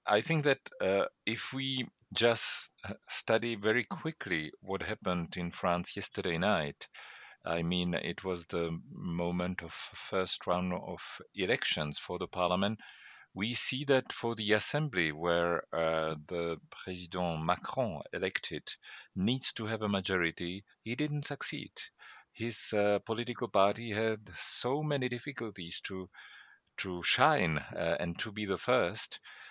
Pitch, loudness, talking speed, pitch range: 100 Hz, -33 LUFS, 135 wpm, 90-115 Hz